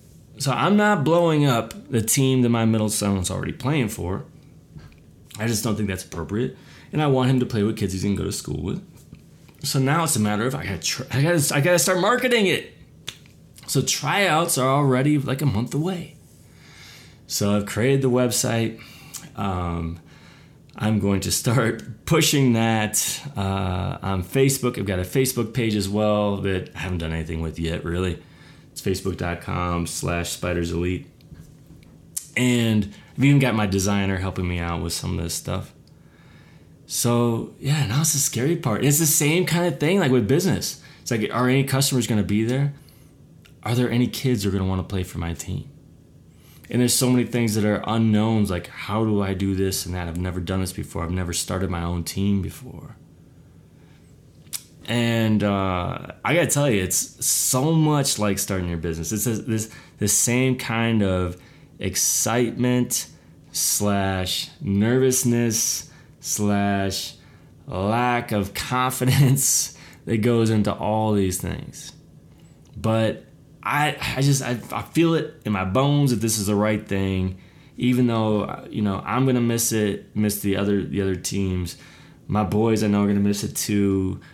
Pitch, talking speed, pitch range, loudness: 110 Hz, 175 wpm, 95-130 Hz, -22 LUFS